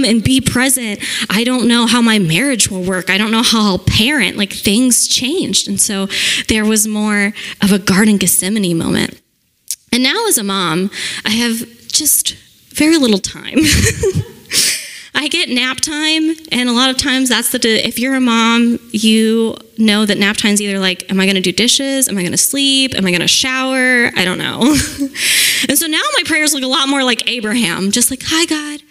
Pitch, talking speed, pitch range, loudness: 235 Hz, 195 wpm, 205-265 Hz, -13 LUFS